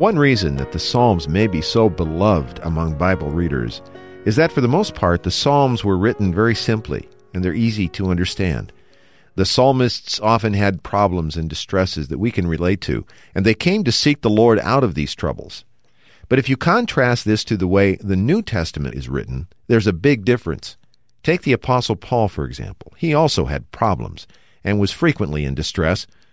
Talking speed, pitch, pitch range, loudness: 190 wpm, 100 Hz, 85-120 Hz, -18 LUFS